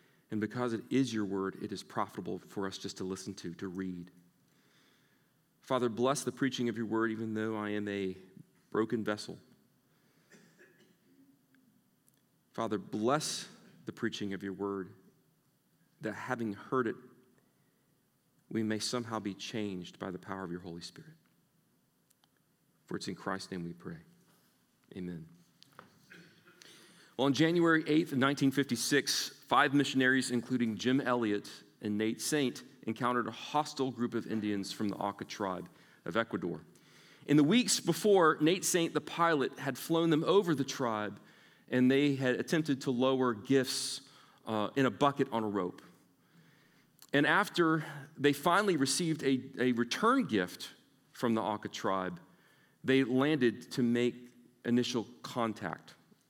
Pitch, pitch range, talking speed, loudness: 120 Hz, 105-140 Hz, 145 wpm, -33 LUFS